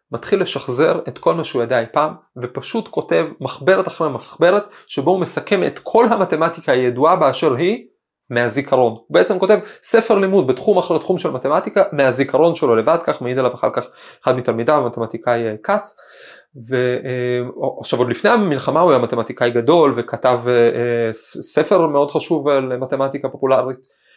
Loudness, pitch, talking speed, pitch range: -17 LUFS, 135 Hz, 150 wpm, 120-165 Hz